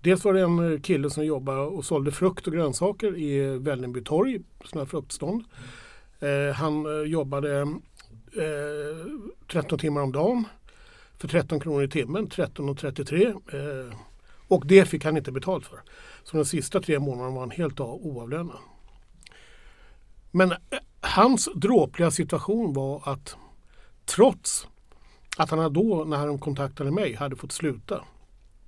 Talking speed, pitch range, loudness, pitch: 130 wpm, 140-175 Hz, -26 LUFS, 150 Hz